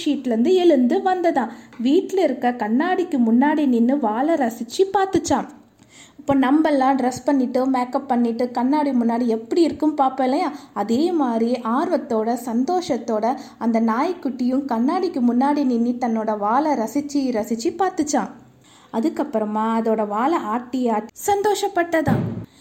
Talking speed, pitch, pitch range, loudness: 110 wpm, 265 Hz, 240-305 Hz, -20 LUFS